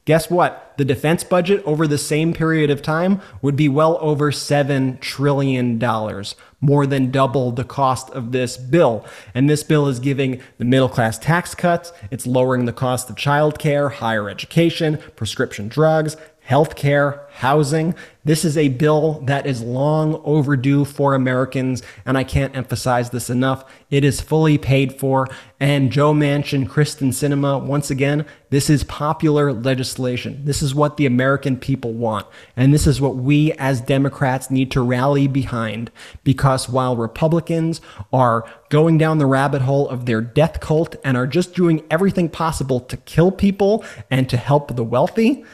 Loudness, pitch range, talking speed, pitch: -18 LUFS, 130-150 Hz, 165 wpm, 140 Hz